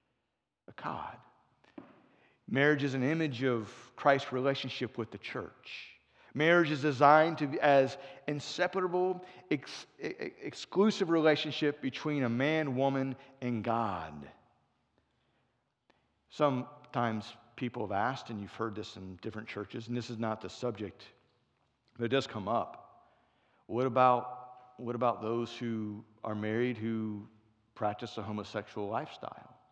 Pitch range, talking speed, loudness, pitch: 110-145 Hz, 125 wpm, -33 LUFS, 125 Hz